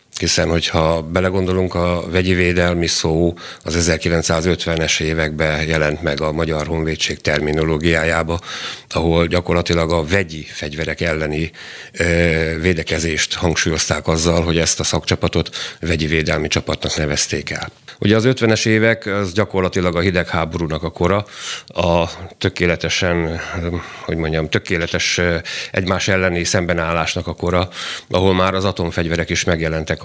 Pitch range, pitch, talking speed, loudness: 80-90 Hz, 85 Hz, 120 wpm, -18 LUFS